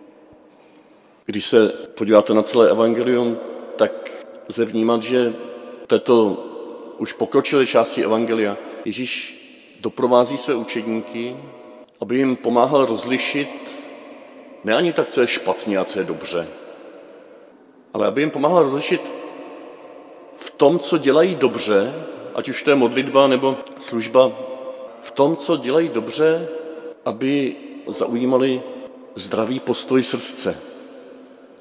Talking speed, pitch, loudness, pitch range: 115 wpm, 130 Hz, -19 LUFS, 120-165 Hz